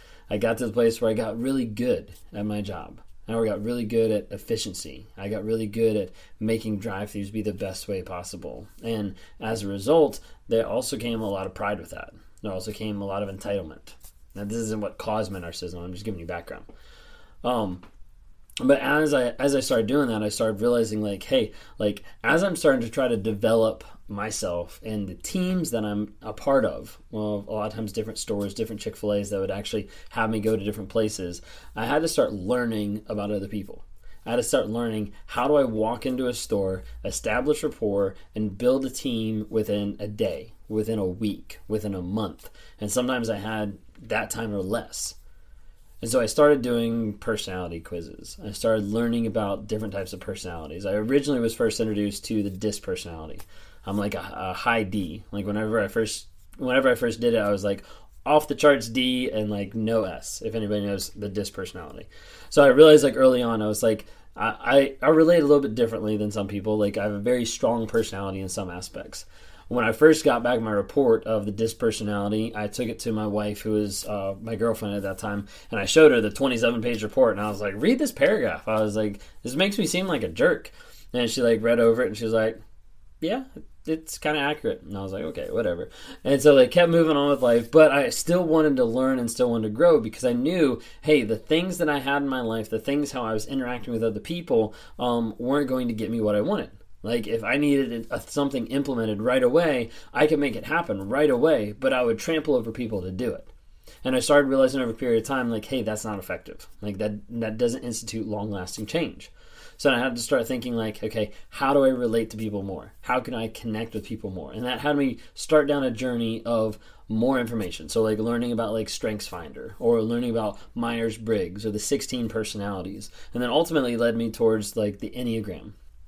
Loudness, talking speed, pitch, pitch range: -25 LUFS, 220 wpm, 110 Hz, 105-125 Hz